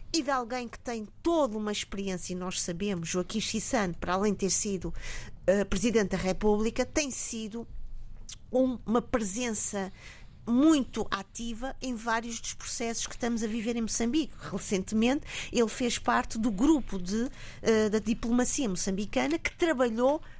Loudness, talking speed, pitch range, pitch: -29 LUFS, 155 wpm, 200-250 Hz, 230 Hz